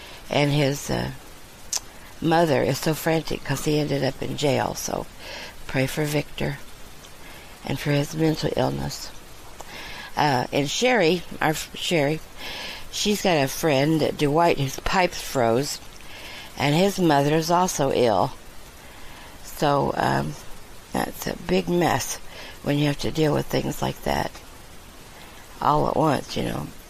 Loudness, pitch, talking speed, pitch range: -23 LUFS, 150 Hz, 135 wpm, 135-165 Hz